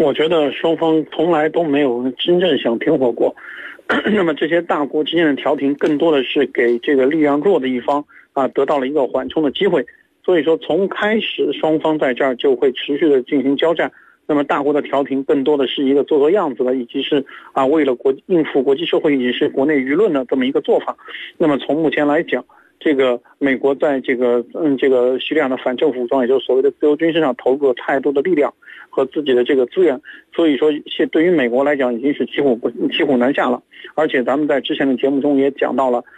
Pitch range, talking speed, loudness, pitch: 135-165 Hz, 340 characters per minute, -17 LUFS, 145 Hz